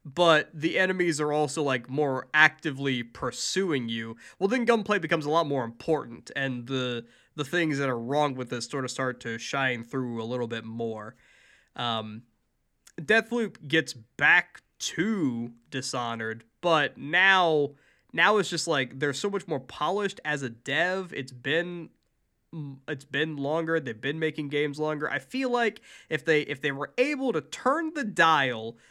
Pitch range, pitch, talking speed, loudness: 125-165 Hz, 145 Hz, 165 wpm, -27 LUFS